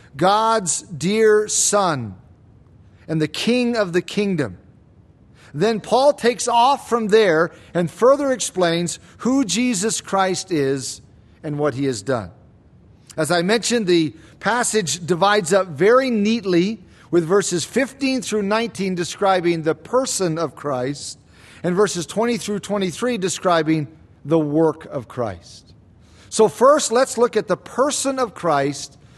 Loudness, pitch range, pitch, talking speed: -19 LUFS, 150-220 Hz, 180 Hz, 135 wpm